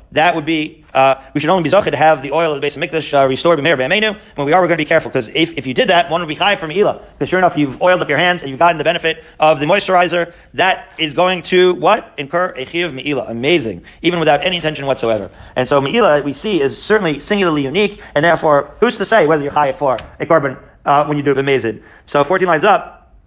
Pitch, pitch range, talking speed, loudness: 155 Hz, 140-175 Hz, 265 wpm, -15 LUFS